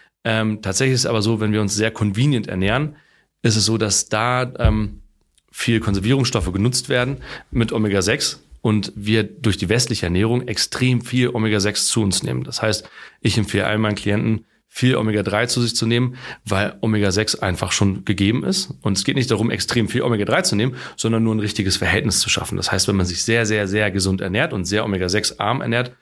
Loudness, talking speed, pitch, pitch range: -19 LUFS, 200 wpm, 110 Hz, 105-120 Hz